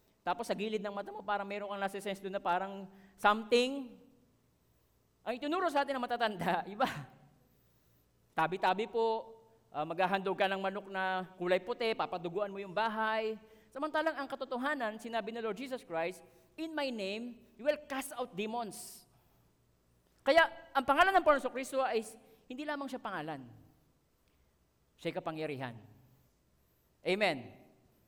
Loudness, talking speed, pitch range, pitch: -35 LUFS, 140 wpm, 175-245 Hz, 210 Hz